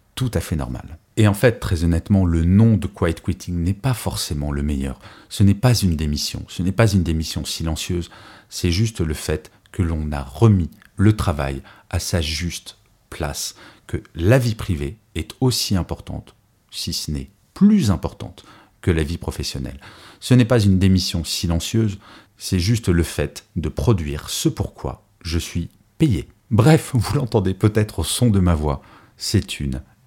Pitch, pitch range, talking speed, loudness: 95 Hz, 80-110 Hz, 175 wpm, -20 LUFS